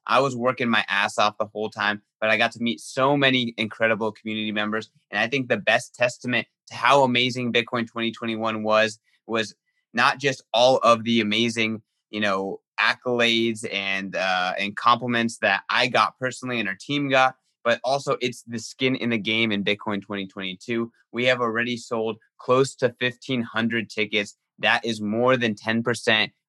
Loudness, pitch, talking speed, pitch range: -23 LUFS, 115 Hz, 175 wpm, 110-125 Hz